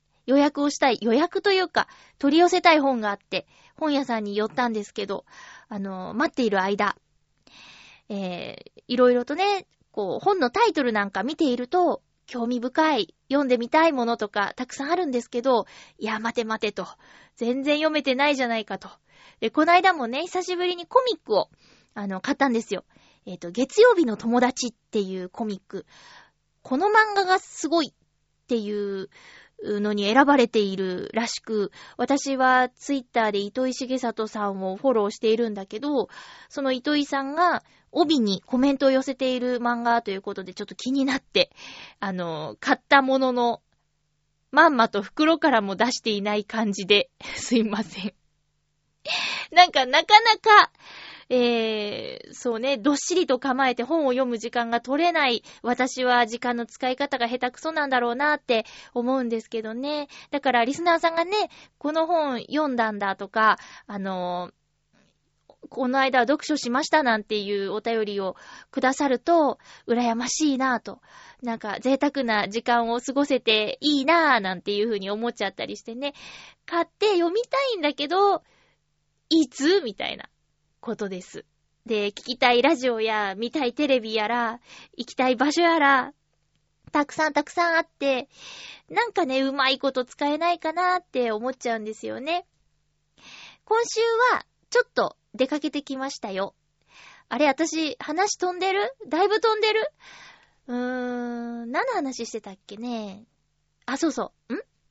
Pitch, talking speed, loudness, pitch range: 255 Hz, 315 characters per minute, -23 LUFS, 220-310 Hz